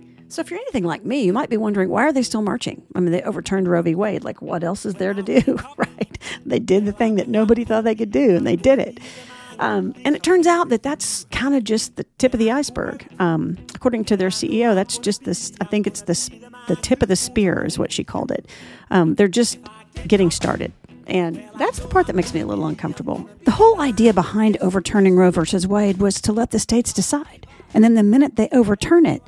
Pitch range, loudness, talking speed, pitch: 190-245 Hz, -19 LUFS, 240 wpm, 215 Hz